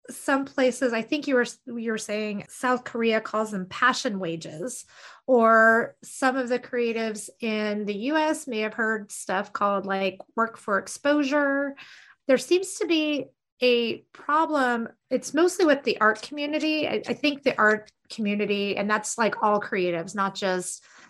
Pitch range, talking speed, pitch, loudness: 210-275 Hz, 160 wpm, 230 Hz, -25 LUFS